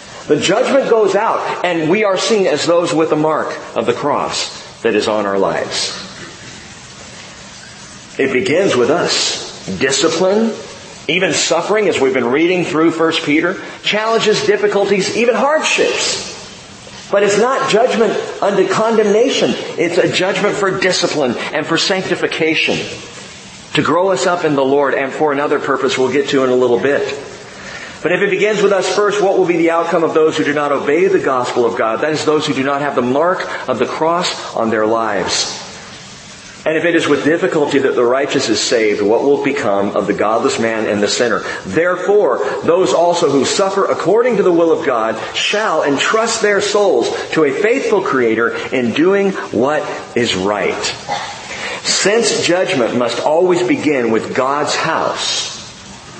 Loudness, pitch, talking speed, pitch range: -14 LUFS, 175 Hz, 170 wpm, 145-205 Hz